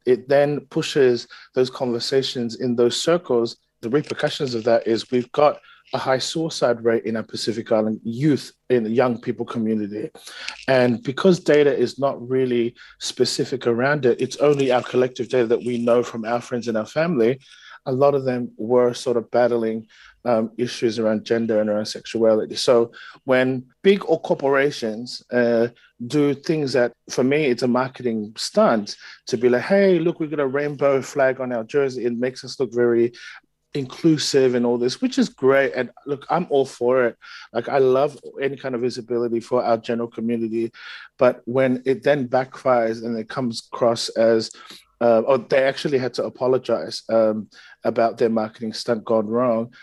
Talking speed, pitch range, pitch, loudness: 180 wpm, 115-135 Hz, 125 Hz, -21 LUFS